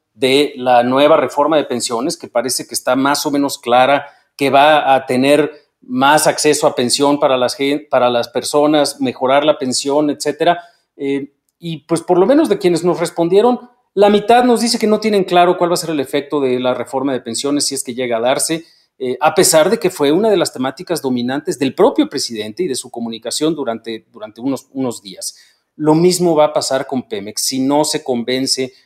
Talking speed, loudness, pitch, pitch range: 210 wpm, -15 LUFS, 145 Hz, 130-165 Hz